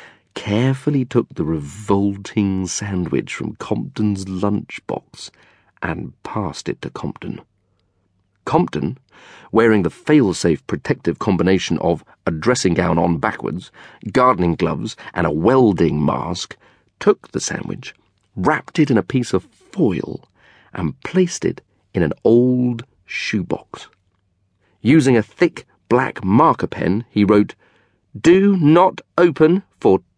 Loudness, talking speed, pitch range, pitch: -18 LUFS, 120 wpm, 95-130 Hz, 105 Hz